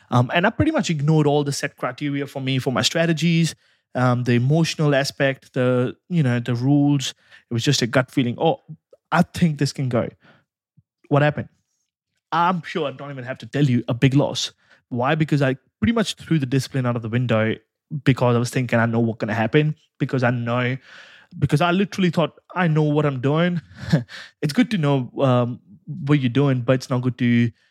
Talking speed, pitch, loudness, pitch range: 210 wpm, 140 Hz, -21 LUFS, 125-155 Hz